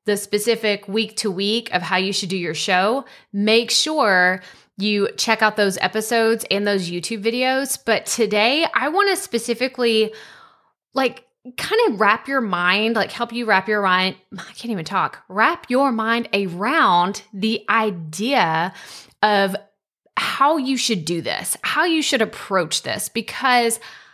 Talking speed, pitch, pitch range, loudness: 155 wpm, 220 Hz, 195-240 Hz, -19 LUFS